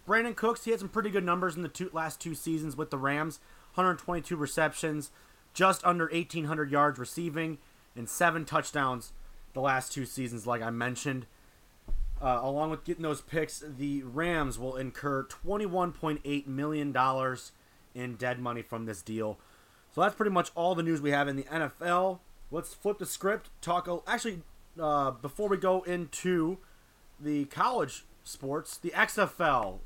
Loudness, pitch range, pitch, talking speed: -31 LUFS, 130-175 Hz, 155 Hz, 165 wpm